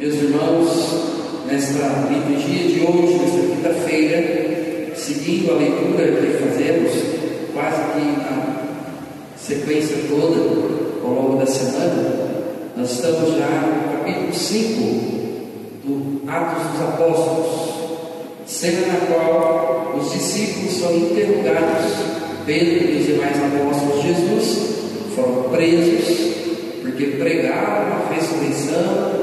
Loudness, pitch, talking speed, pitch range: -19 LUFS, 160 Hz, 105 wpm, 145-165 Hz